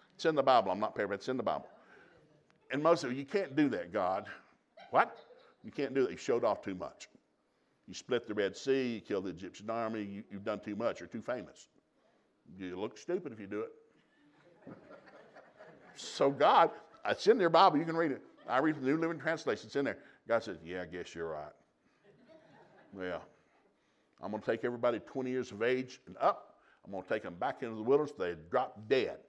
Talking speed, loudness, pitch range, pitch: 215 wpm, -34 LUFS, 105-160 Hz, 125 Hz